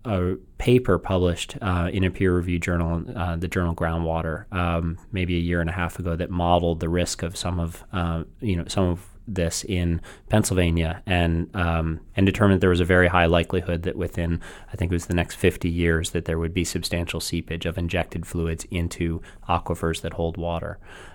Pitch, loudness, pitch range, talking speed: 85 Hz, -24 LUFS, 85-90 Hz, 195 wpm